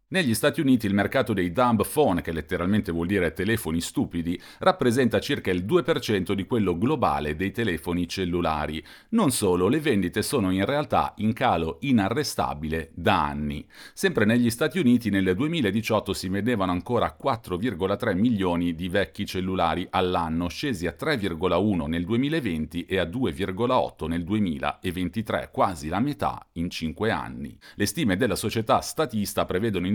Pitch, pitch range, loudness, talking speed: 95 Hz, 85-115 Hz, -25 LUFS, 150 wpm